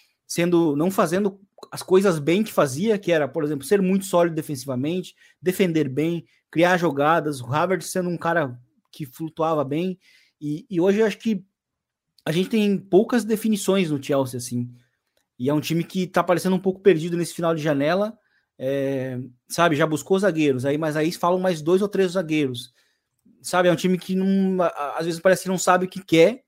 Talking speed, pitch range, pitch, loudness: 195 wpm, 150-190 Hz, 170 Hz, -22 LUFS